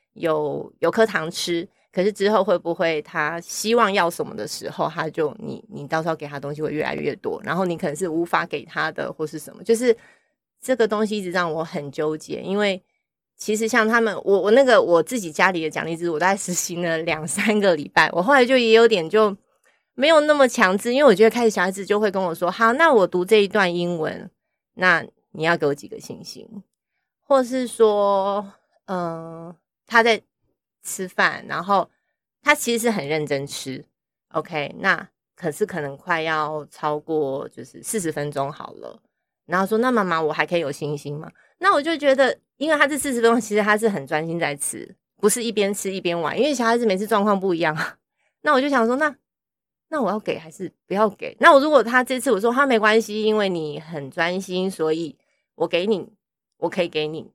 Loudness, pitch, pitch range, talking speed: -21 LUFS, 195 Hz, 165-225 Hz, 295 characters per minute